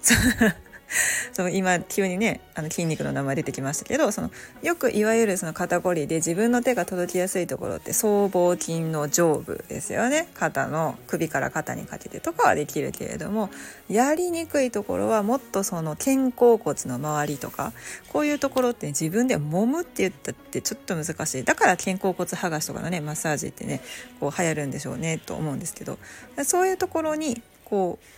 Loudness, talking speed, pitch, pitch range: -25 LUFS, 380 characters per minute, 185 Hz, 160-240 Hz